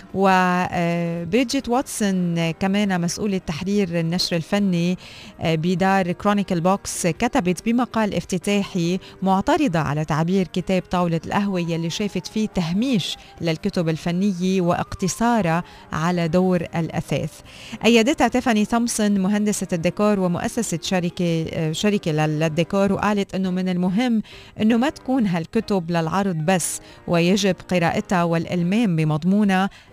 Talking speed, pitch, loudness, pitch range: 105 wpm, 185 Hz, -21 LUFS, 170-205 Hz